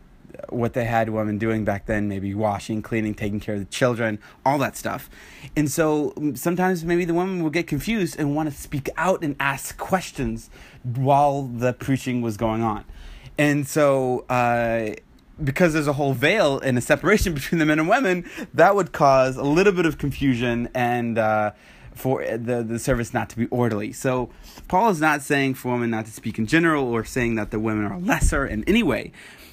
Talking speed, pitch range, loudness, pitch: 190 wpm, 115-150 Hz, -22 LUFS, 130 Hz